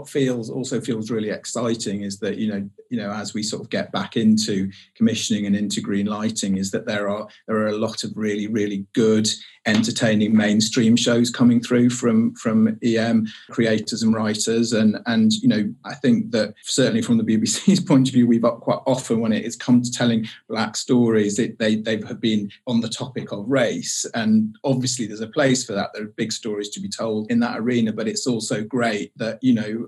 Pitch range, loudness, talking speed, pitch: 110-130 Hz, -21 LUFS, 215 wpm, 115 Hz